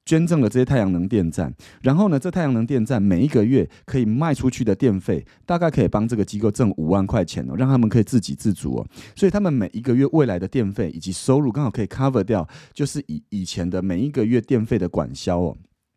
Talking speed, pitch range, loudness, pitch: 370 characters per minute, 95-135 Hz, -21 LUFS, 115 Hz